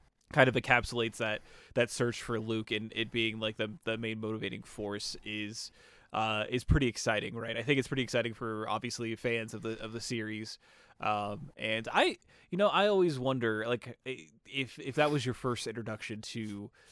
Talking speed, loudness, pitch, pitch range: 190 wpm, -33 LUFS, 115 Hz, 110-125 Hz